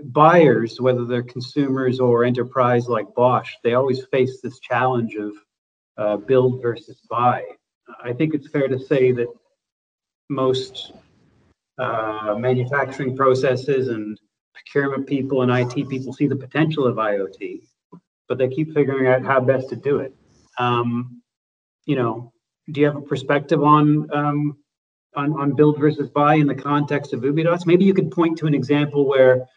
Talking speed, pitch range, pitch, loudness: 160 wpm, 125-145 Hz, 130 Hz, -20 LUFS